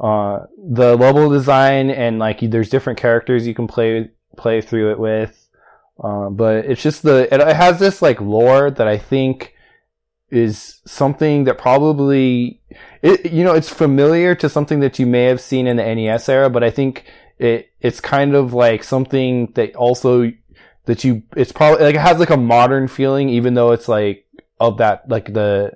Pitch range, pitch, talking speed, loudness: 115-140 Hz, 125 Hz, 185 wpm, -15 LUFS